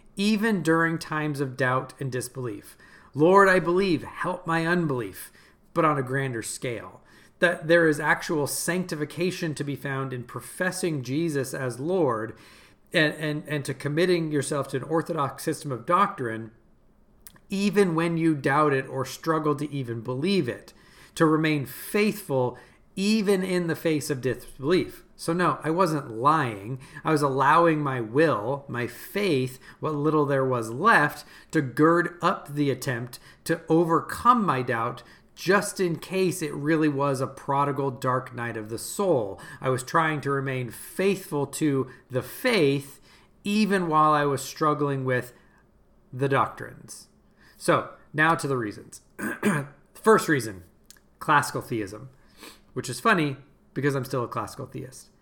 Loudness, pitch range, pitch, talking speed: -25 LUFS, 130-170 Hz, 150 Hz, 150 wpm